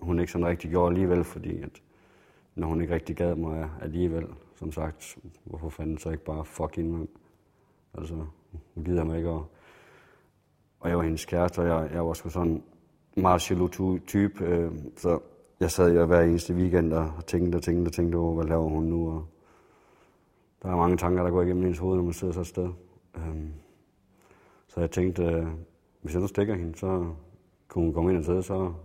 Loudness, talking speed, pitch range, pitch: -28 LUFS, 200 wpm, 80-90 Hz, 85 Hz